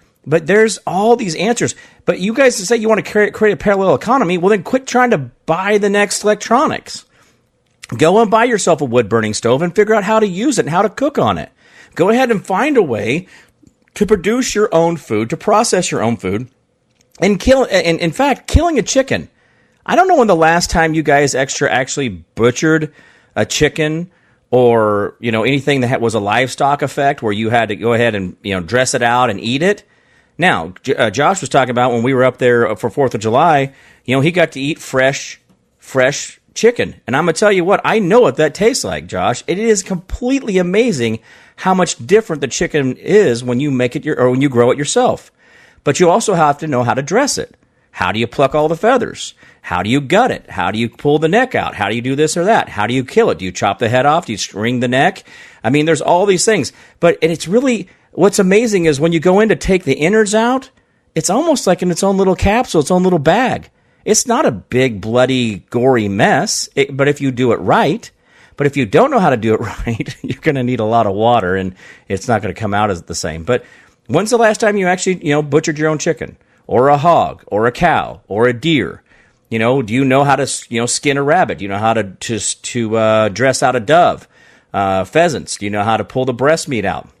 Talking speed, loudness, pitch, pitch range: 245 wpm, -14 LUFS, 150 Hz, 120-200 Hz